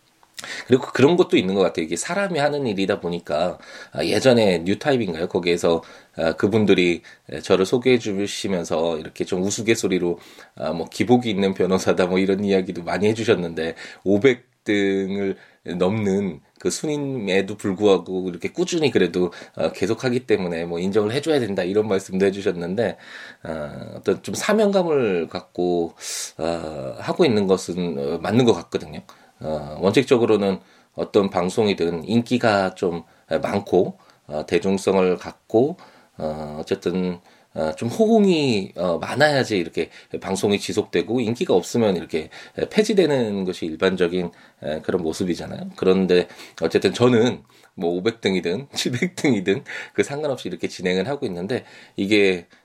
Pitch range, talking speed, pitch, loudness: 85-115 Hz, 305 characters per minute, 95 Hz, -21 LUFS